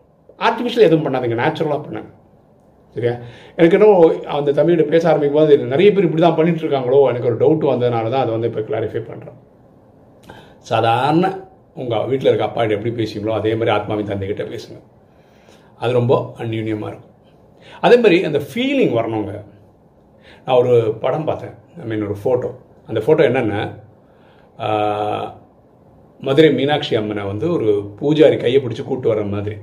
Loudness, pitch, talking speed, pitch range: -17 LUFS, 120 Hz, 140 wpm, 105-160 Hz